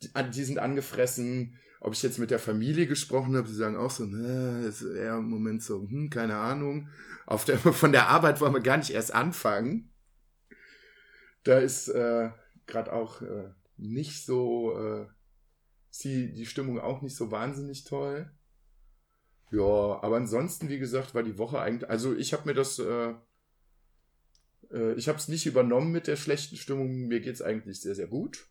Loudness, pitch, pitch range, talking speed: -29 LUFS, 125 Hz, 115-140 Hz, 175 wpm